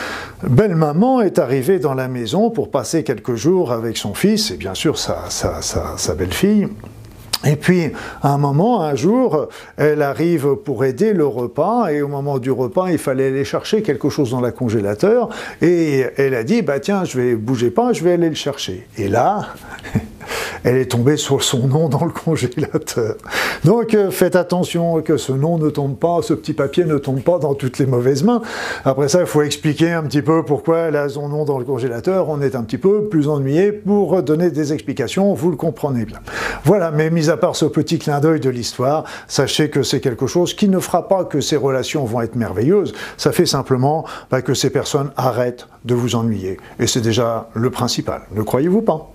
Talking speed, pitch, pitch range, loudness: 210 wpm, 150 Hz, 130-170 Hz, -17 LUFS